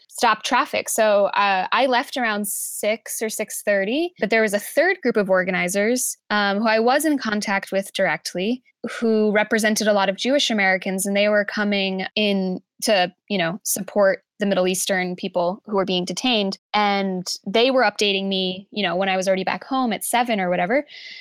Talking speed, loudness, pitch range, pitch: 190 wpm, -21 LUFS, 190-230 Hz, 205 Hz